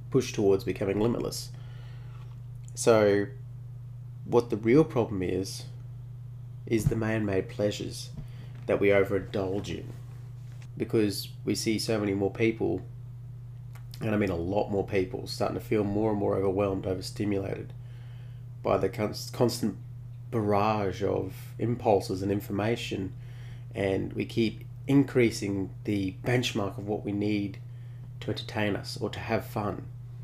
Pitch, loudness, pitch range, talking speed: 120 Hz, -29 LUFS, 105-120 Hz, 130 wpm